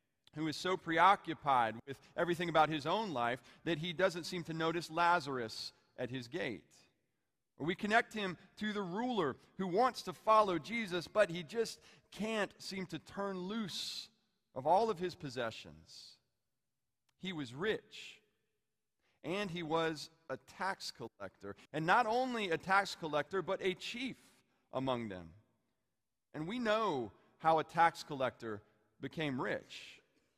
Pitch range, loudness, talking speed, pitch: 130-195 Hz, -36 LUFS, 145 wpm, 165 Hz